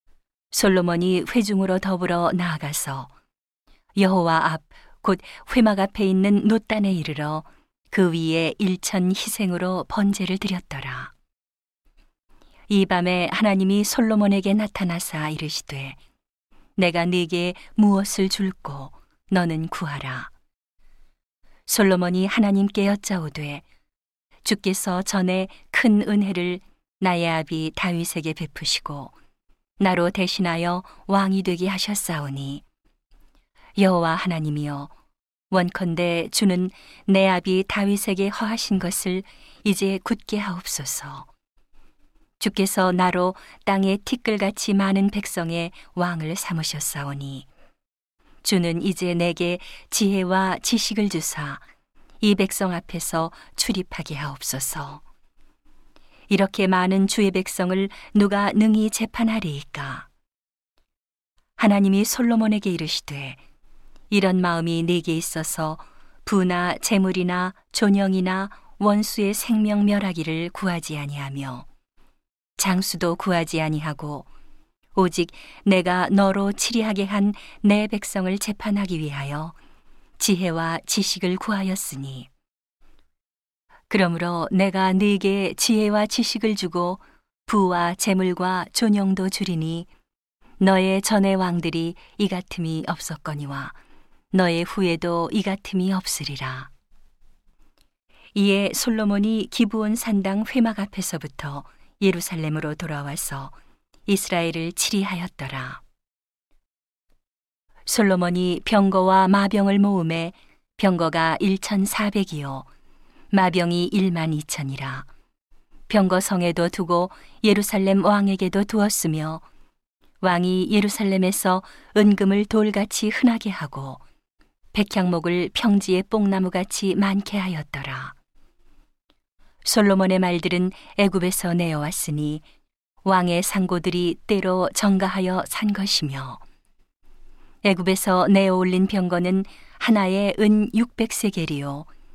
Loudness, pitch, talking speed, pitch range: -22 LUFS, 185 Hz, 235 characters per minute, 170-200 Hz